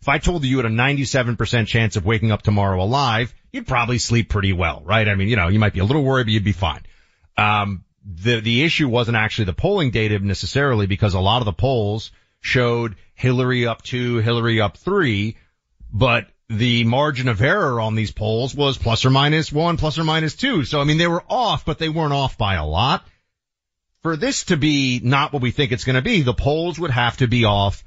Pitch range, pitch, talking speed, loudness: 105-140 Hz, 120 Hz, 230 wpm, -19 LUFS